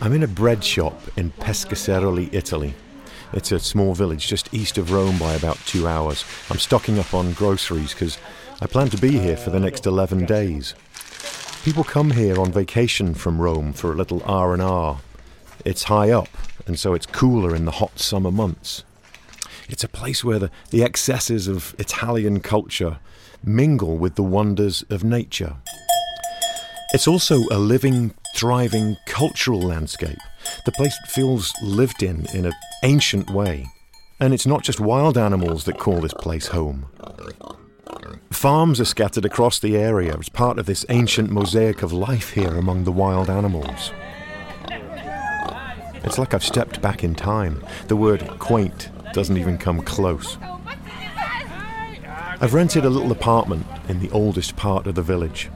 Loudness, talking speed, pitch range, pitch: -21 LUFS, 160 wpm, 90-115 Hz, 100 Hz